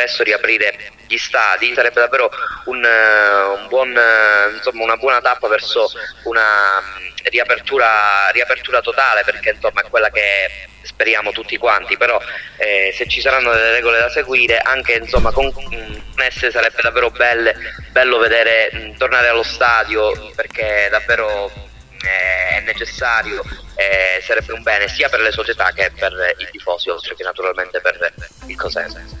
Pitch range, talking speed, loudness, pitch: 105-135 Hz, 145 wpm, -15 LUFS, 115 Hz